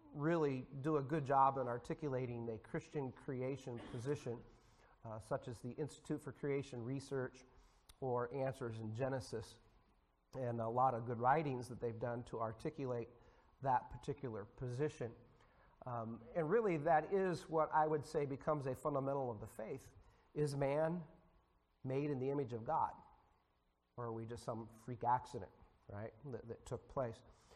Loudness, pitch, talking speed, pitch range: -42 LUFS, 125 Hz, 155 wpm, 115-140 Hz